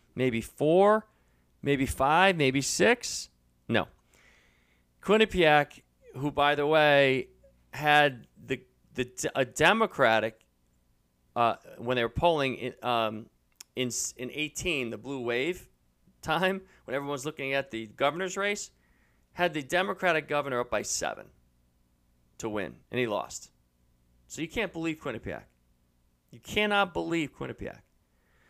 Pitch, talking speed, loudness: 125 Hz, 125 wpm, -28 LUFS